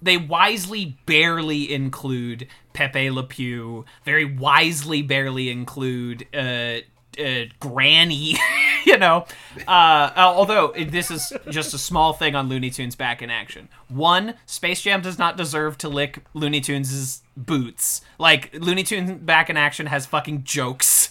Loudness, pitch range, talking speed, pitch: -19 LUFS, 130-160 Hz, 140 wpm, 145 Hz